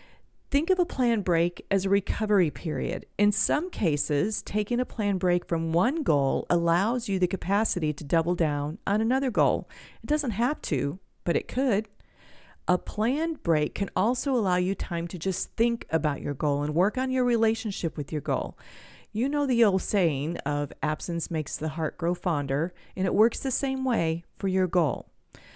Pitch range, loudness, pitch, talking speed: 160-230 Hz, -26 LUFS, 185 Hz, 185 wpm